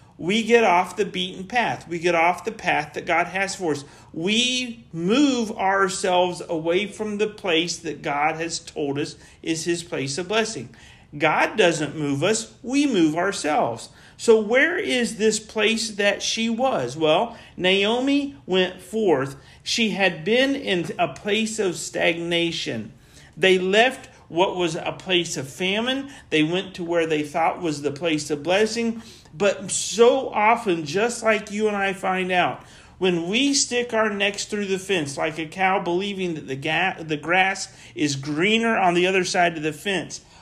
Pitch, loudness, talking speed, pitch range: 185 Hz, -22 LUFS, 170 wpm, 165-220 Hz